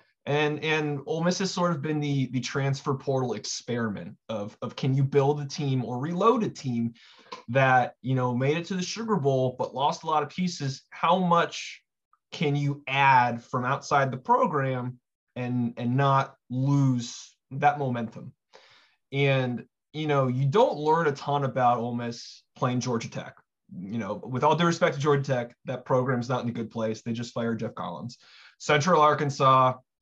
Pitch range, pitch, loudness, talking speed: 125-150 Hz, 135 Hz, -26 LUFS, 180 wpm